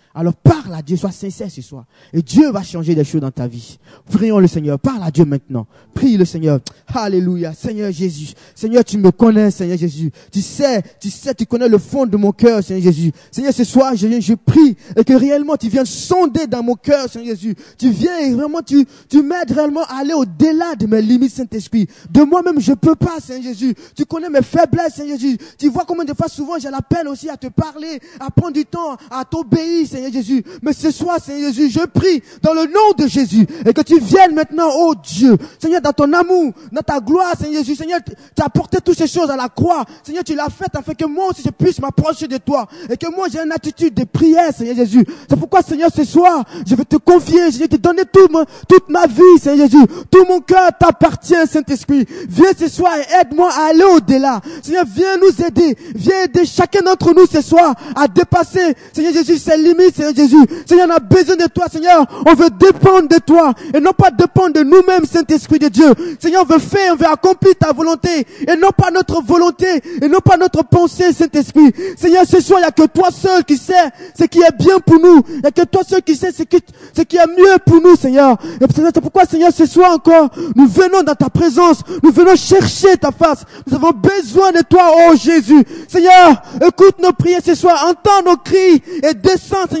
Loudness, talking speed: -12 LUFS, 225 wpm